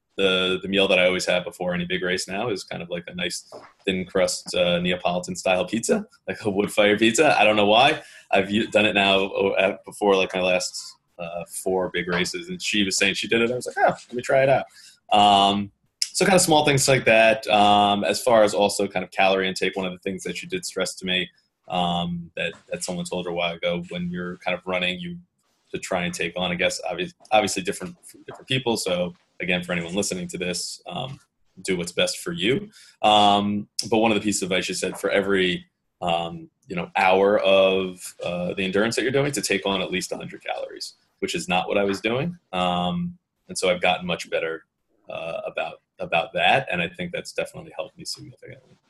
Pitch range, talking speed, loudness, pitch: 90-105 Hz, 225 wpm, -22 LUFS, 95 Hz